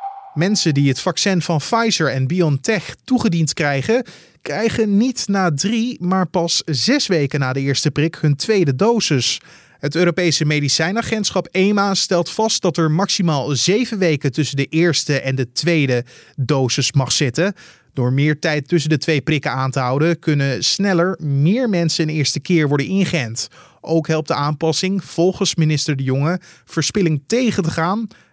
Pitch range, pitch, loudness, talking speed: 145-190 Hz, 165 Hz, -17 LUFS, 160 wpm